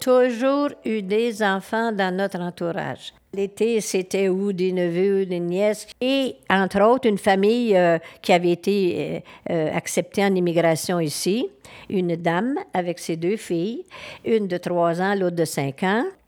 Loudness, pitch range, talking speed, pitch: -22 LUFS, 175-220 Hz, 160 wpm, 195 Hz